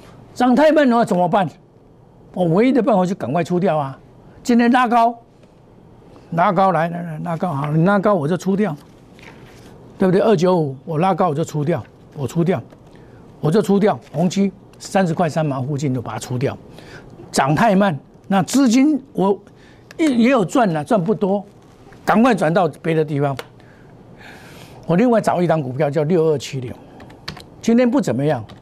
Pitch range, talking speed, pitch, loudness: 145-205 Hz, 240 characters per minute, 170 Hz, -18 LUFS